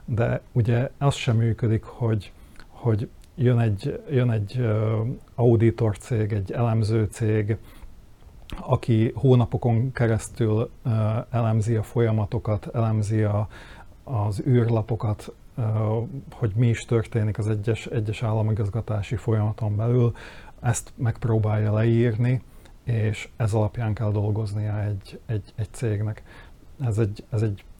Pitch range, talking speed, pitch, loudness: 110-120 Hz, 110 wpm, 110 Hz, -25 LUFS